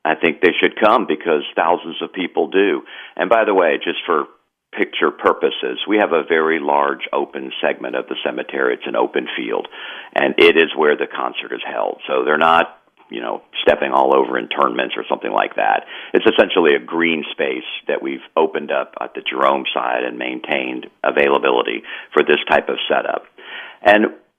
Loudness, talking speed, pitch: -17 LUFS, 195 wpm, 380 Hz